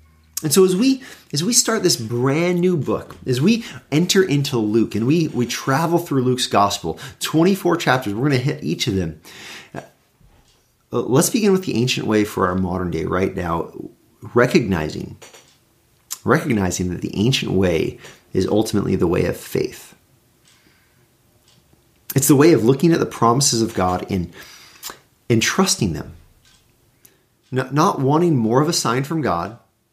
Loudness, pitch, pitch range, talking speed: -19 LUFS, 125 Hz, 105-160 Hz, 160 wpm